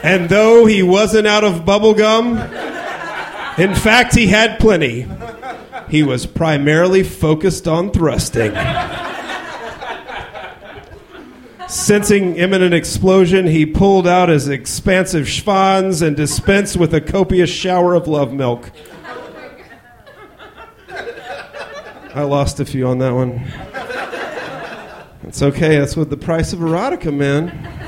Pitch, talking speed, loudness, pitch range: 170 Hz, 110 wpm, -14 LUFS, 145-195 Hz